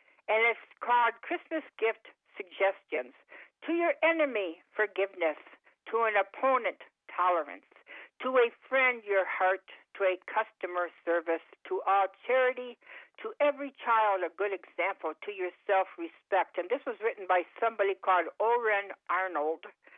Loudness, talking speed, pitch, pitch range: -30 LUFS, 130 wpm, 215 Hz, 190-255 Hz